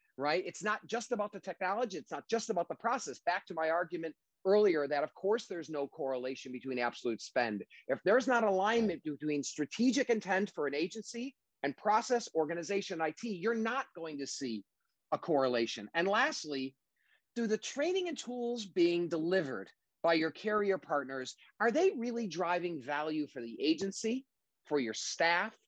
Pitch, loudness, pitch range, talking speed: 180 Hz, -34 LUFS, 150-225 Hz, 170 wpm